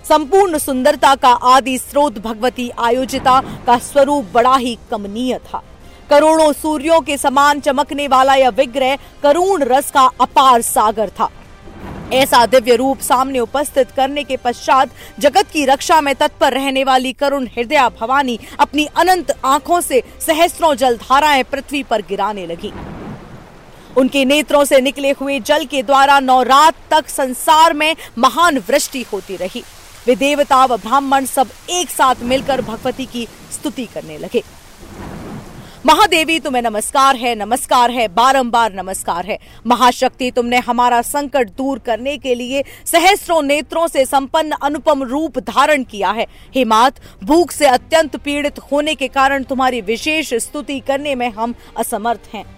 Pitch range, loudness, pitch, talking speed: 245-290 Hz, -14 LUFS, 270 Hz, 145 wpm